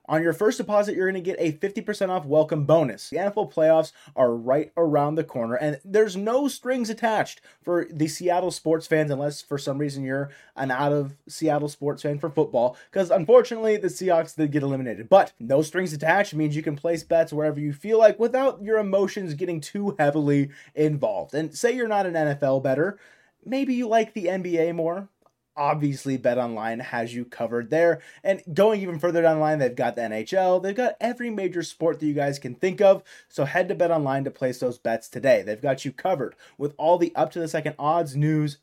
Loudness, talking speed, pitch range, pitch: -24 LUFS, 210 wpm, 145-190 Hz, 160 Hz